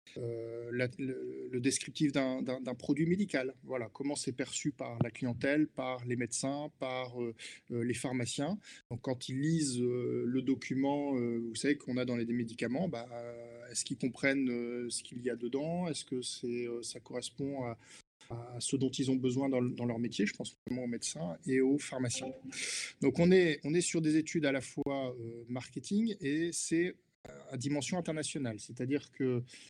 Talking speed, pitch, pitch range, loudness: 195 wpm, 130 Hz, 120-145 Hz, -35 LUFS